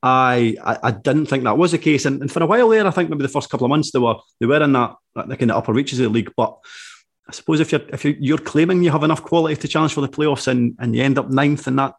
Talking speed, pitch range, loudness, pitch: 305 wpm, 130-160 Hz, -18 LUFS, 145 Hz